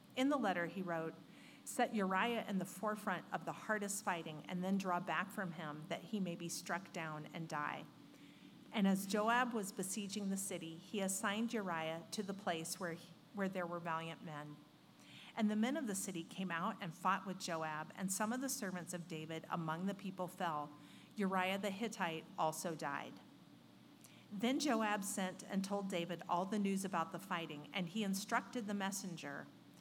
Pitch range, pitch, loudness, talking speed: 165-205 Hz, 185 Hz, -41 LUFS, 185 wpm